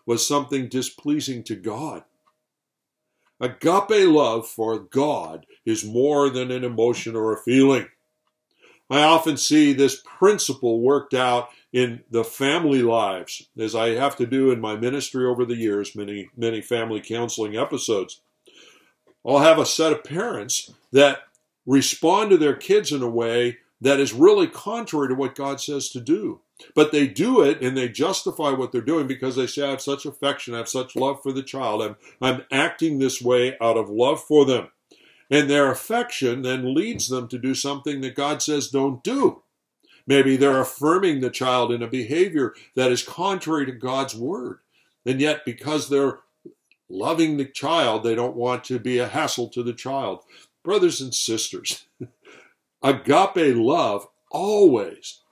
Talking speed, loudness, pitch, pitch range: 165 wpm, -21 LUFS, 130 Hz, 120-145 Hz